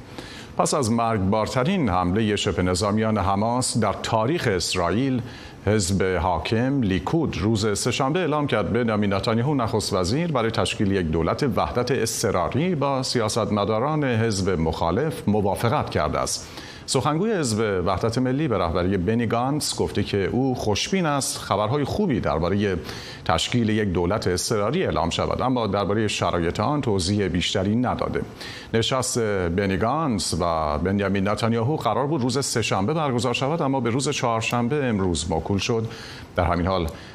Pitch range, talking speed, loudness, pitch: 95-125 Hz, 135 wpm, -23 LUFS, 110 Hz